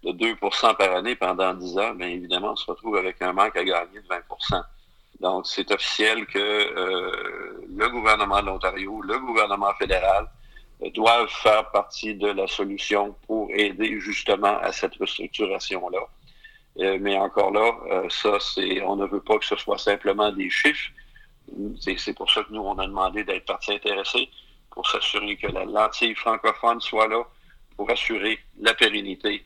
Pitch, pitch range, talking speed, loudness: 105 Hz, 95-115 Hz, 175 wpm, -23 LUFS